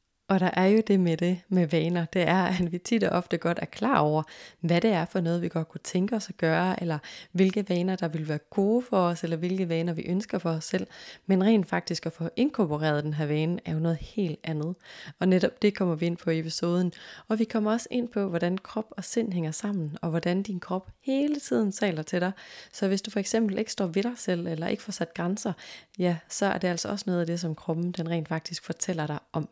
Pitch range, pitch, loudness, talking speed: 165-200 Hz, 180 Hz, -28 LUFS, 255 wpm